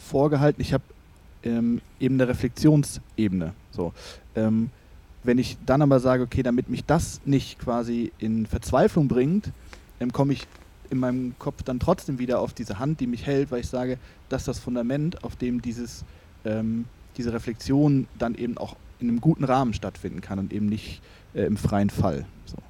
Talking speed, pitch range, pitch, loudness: 180 wpm, 110-130 Hz, 120 Hz, -25 LUFS